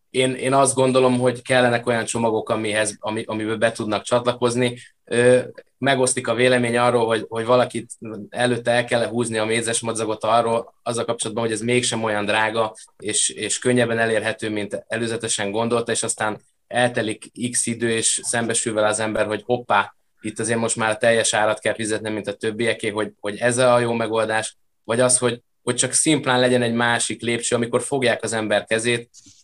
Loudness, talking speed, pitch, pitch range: -20 LUFS, 175 wpm, 115 Hz, 110-120 Hz